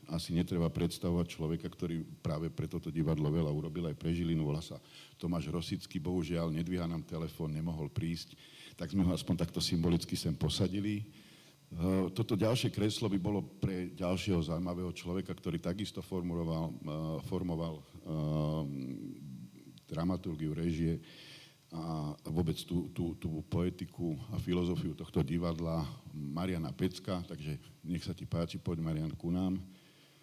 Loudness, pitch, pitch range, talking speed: -36 LUFS, 85 Hz, 80-90 Hz, 135 wpm